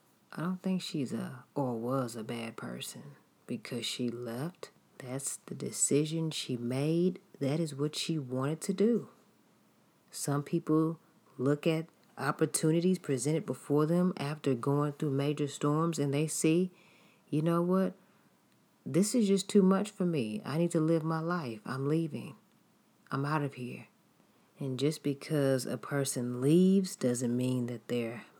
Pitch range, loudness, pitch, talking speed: 135-170 Hz, -32 LUFS, 150 Hz, 155 wpm